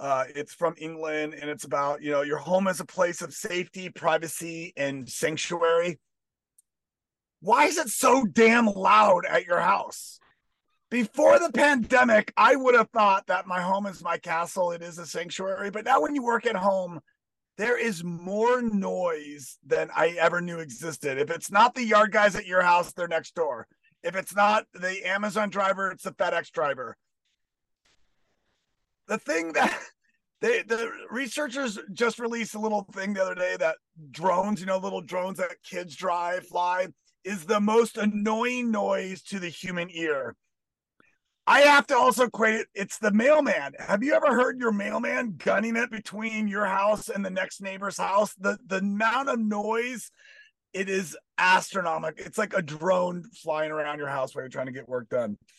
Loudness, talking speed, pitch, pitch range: -25 LUFS, 175 wpm, 195 Hz, 170-225 Hz